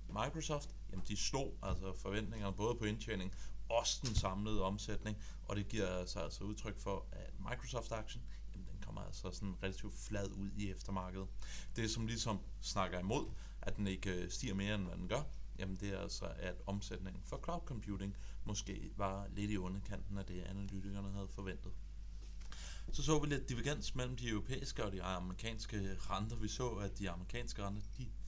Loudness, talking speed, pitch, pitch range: -43 LUFS, 175 wpm, 100 Hz, 95-110 Hz